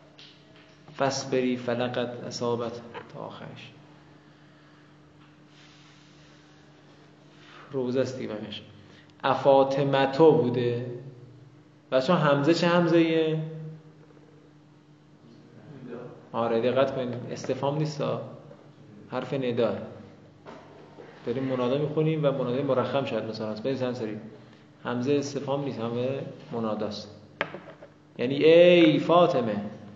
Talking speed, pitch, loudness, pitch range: 80 wpm, 135 Hz, -26 LUFS, 125-150 Hz